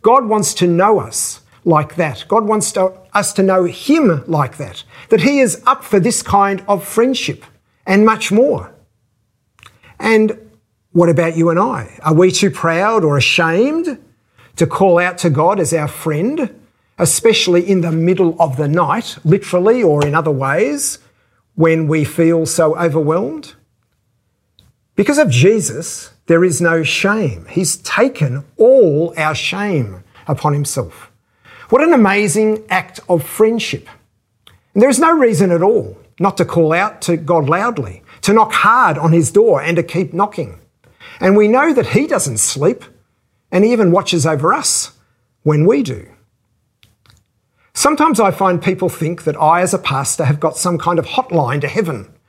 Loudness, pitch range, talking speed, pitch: -14 LUFS, 145-205 Hz, 165 wpm, 170 Hz